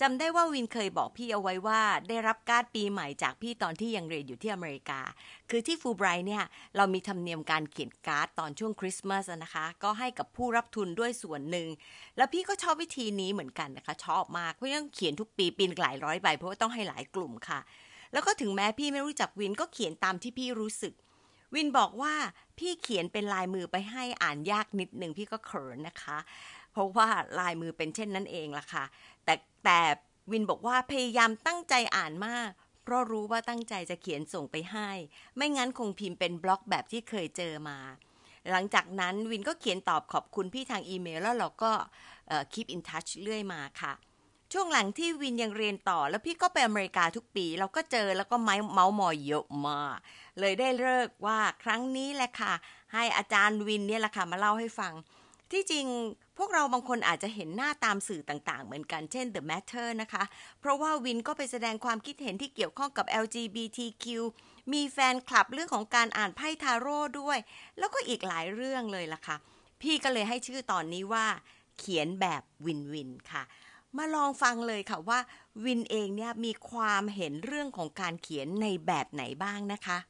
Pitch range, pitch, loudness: 185-245 Hz, 215 Hz, -32 LUFS